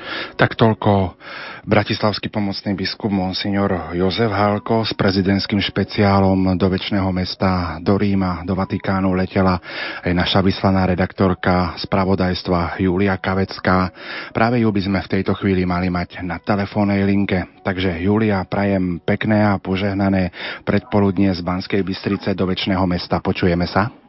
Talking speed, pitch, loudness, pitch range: 130 wpm, 95 Hz, -19 LUFS, 95-100 Hz